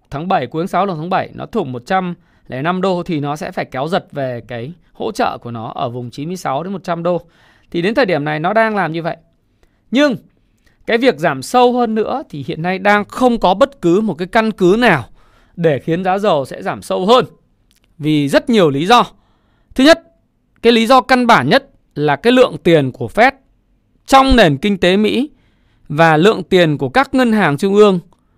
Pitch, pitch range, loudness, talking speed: 180 Hz, 155-225 Hz, -14 LUFS, 215 wpm